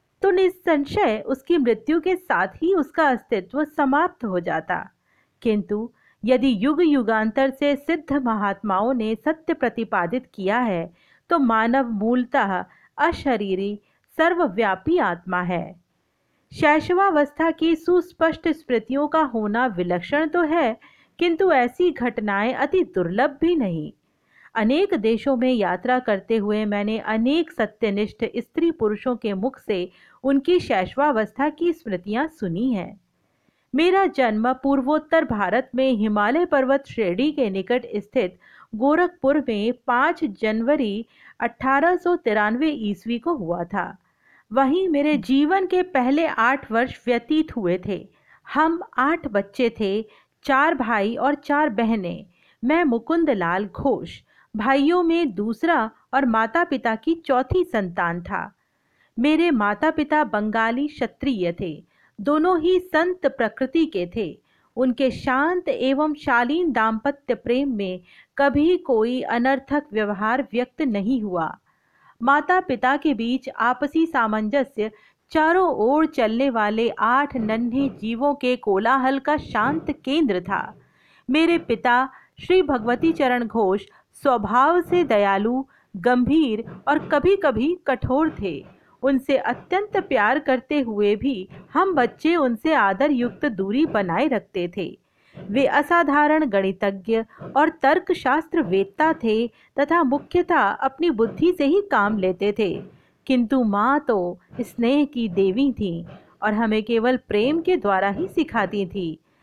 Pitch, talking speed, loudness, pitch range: 260 Hz, 115 wpm, -21 LUFS, 220-305 Hz